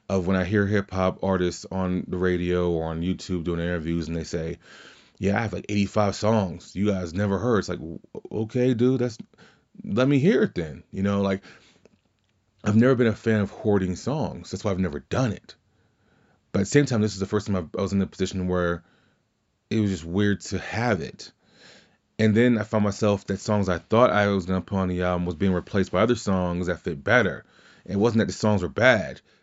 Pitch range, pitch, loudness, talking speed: 90-110 Hz, 100 Hz, -24 LUFS, 225 wpm